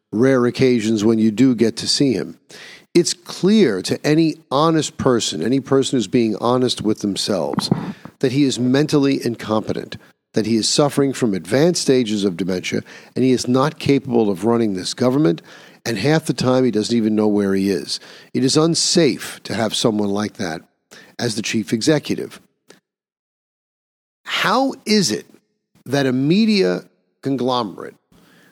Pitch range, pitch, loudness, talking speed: 110-150 Hz, 125 Hz, -18 LUFS, 160 wpm